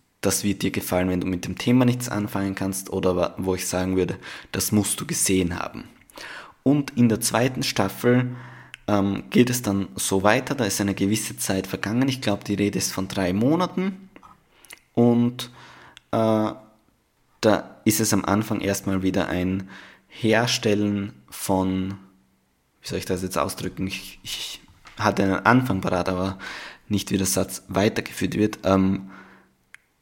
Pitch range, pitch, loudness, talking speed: 95-110 Hz, 100 Hz, -23 LUFS, 160 wpm